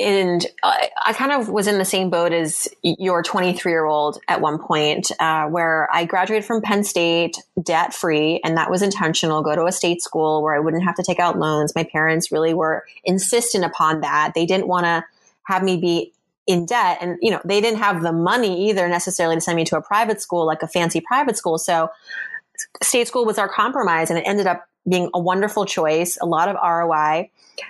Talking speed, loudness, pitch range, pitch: 215 wpm, -19 LUFS, 165-195 Hz, 175 Hz